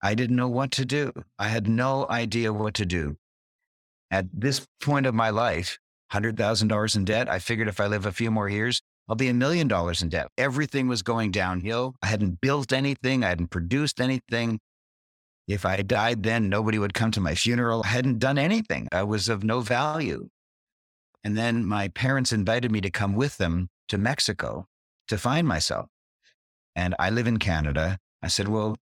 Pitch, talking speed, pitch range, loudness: 110 Hz, 195 wpm, 100-125 Hz, -26 LUFS